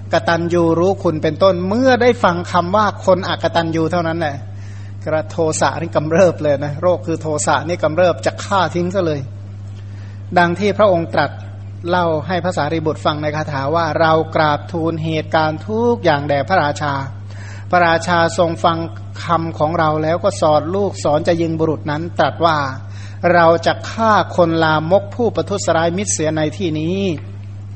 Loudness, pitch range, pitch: -16 LUFS, 135-170 Hz, 160 Hz